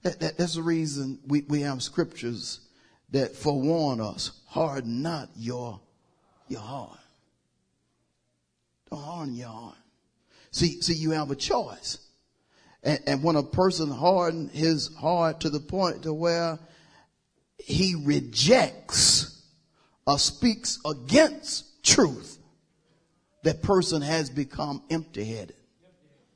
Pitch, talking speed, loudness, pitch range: 155 Hz, 105 wpm, -26 LUFS, 135-170 Hz